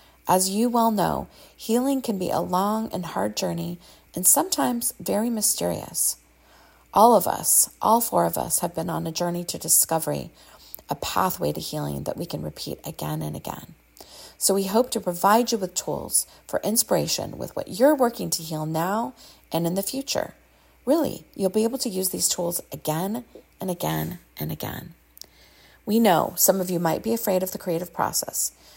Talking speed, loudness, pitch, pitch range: 180 wpm, -23 LUFS, 185 Hz, 165-225 Hz